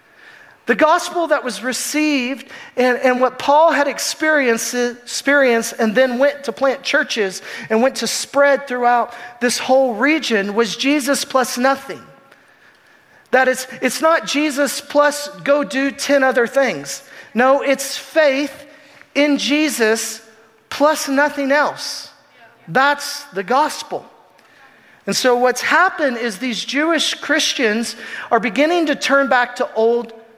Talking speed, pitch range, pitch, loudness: 130 wpm, 240-290 Hz, 270 Hz, -17 LUFS